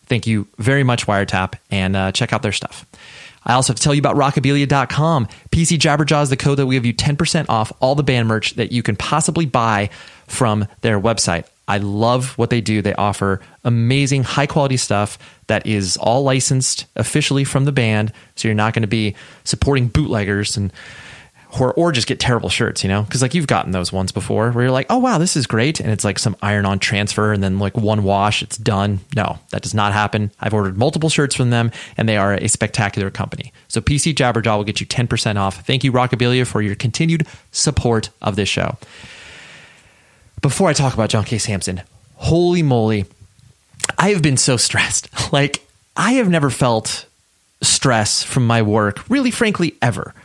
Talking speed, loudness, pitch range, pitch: 200 wpm, -17 LUFS, 105-135 Hz, 115 Hz